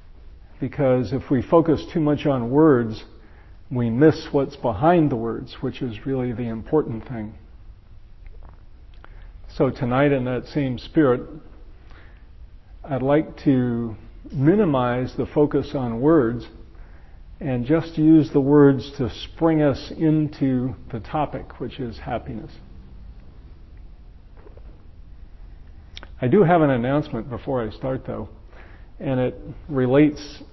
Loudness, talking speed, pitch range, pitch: -21 LUFS, 120 wpm, 90-140 Hz, 120 Hz